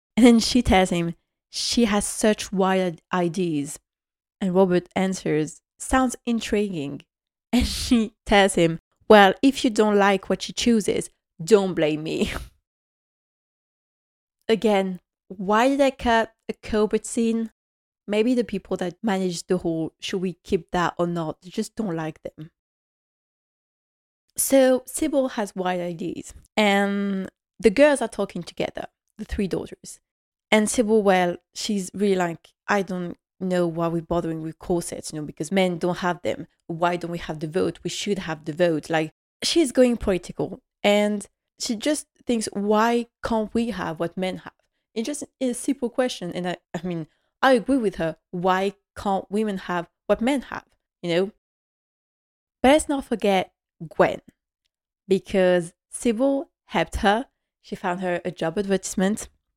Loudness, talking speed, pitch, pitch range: -23 LUFS, 155 wpm, 195 Hz, 175-225 Hz